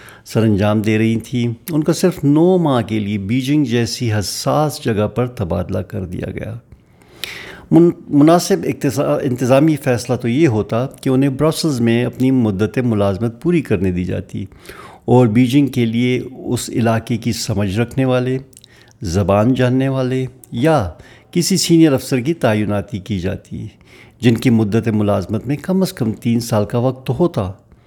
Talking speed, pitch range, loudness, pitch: 155 wpm, 110-135 Hz, -16 LUFS, 120 Hz